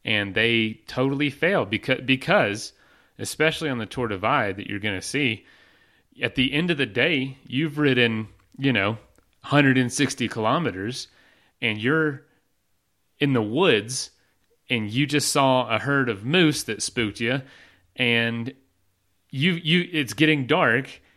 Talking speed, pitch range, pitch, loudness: 145 wpm, 110-145 Hz, 125 Hz, -23 LUFS